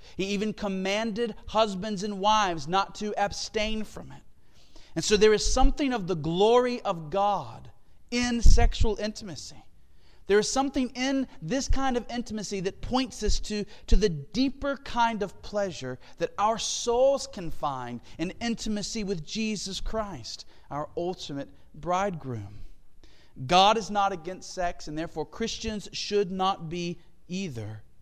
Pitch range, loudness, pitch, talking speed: 165-220 Hz, -28 LUFS, 200 Hz, 145 wpm